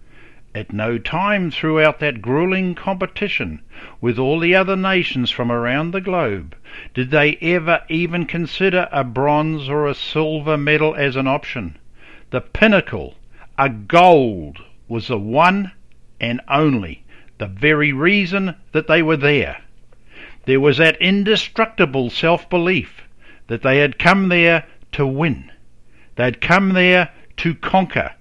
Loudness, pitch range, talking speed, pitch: -17 LUFS, 125-175 Hz, 135 wpm, 155 Hz